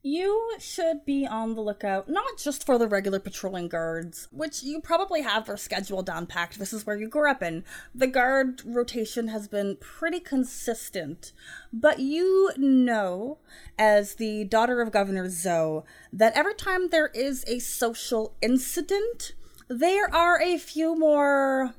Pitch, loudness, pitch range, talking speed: 245 Hz, -26 LUFS, 210-305 Hz, 155 wpm